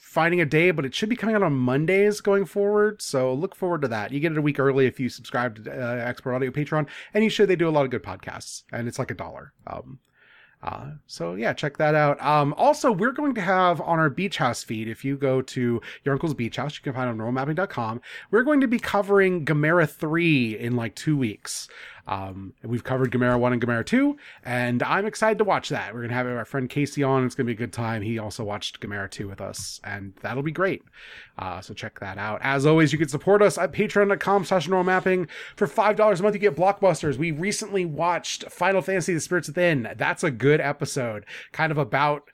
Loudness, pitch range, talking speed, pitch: -24 LUFS, 120-185 Hz, 235 wpm, 145 Hz